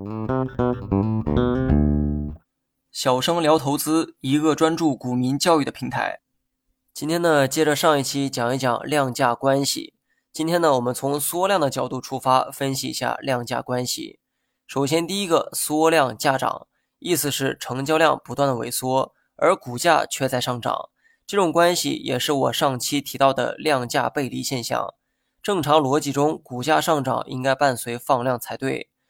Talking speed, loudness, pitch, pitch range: 235 characters per minute, -22 LUFS, 140 Hz, 125-155 Hz